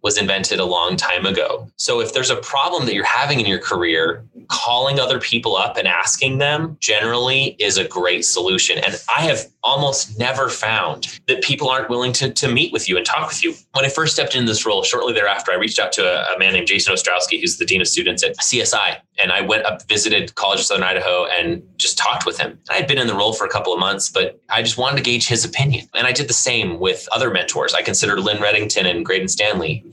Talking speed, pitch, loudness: 245 wpm, 140 Hz, -17 LUFS